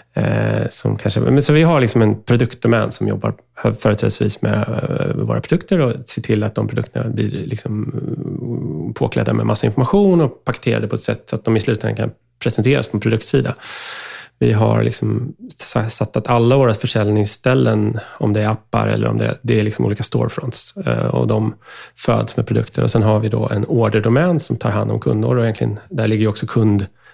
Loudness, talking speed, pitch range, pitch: -17 LUFS, 190 wpm, 110-130 Hz, 115 Hz